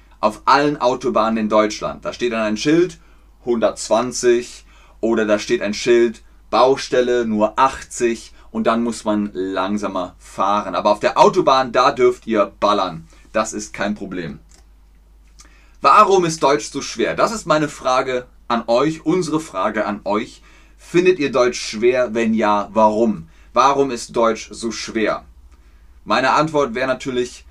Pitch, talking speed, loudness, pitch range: 115 Hz, 150 wpm, -18 LUFS, 105-135 Hz